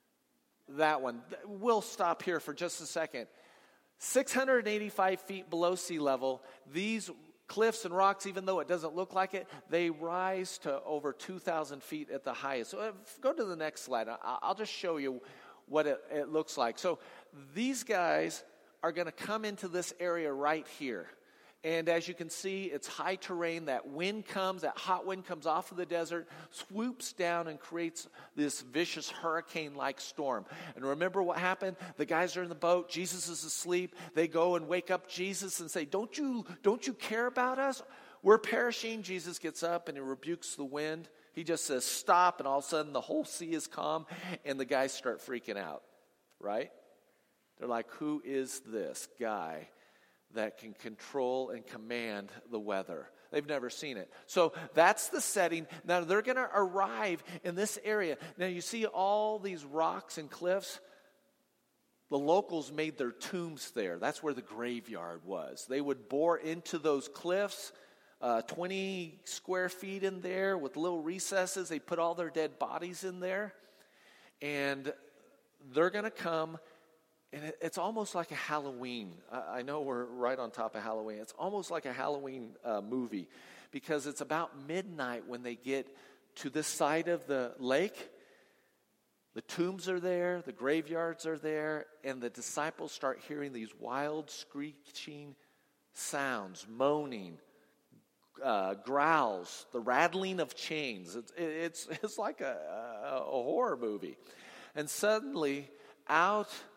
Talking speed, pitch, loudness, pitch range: 165 wpm, 165 Hz, -35 LUFS, 145-185 Hz